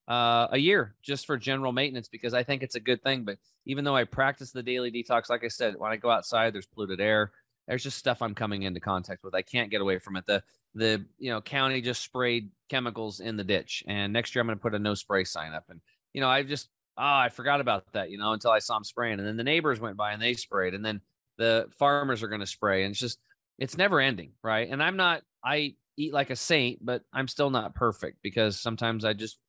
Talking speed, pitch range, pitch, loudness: 255 wpm, 105-130 Hz, 120 Hz, -28 LUFS